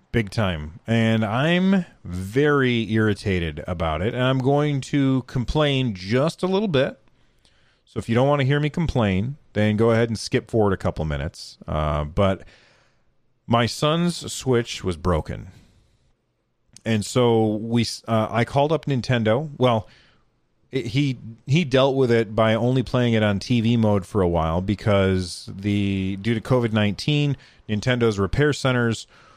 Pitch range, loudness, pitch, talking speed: 105-130 Hz, -22 LUFS, 115 Hz, 155 wpm